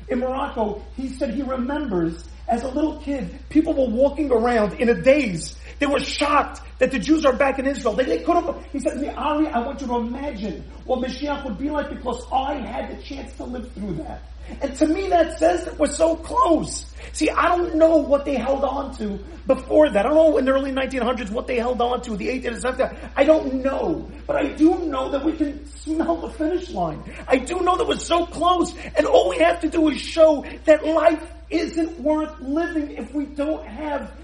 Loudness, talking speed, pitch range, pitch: -21 LUFS, 225 wpm, 255-315 Hz, 285 Hz